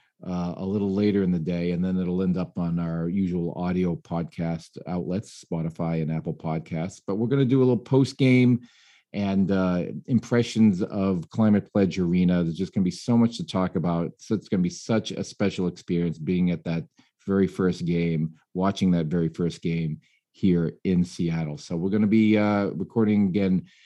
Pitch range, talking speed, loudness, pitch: 85-100 Hz, 195 wpm, -25 LUFS, 90 Hz